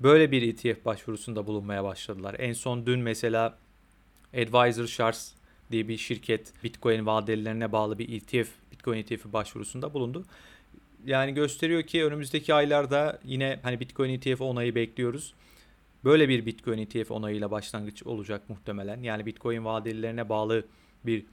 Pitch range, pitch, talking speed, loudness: 110-125 Hz, 115 Hz, 135 wpm, -29 LUFS